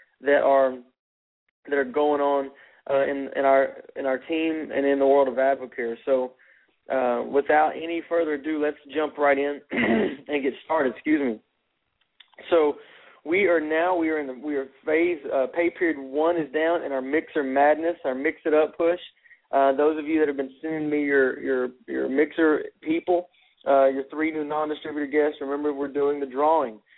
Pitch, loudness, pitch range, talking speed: 150 Hz, -24 LUFS, 135-160 Hz, 190 wpm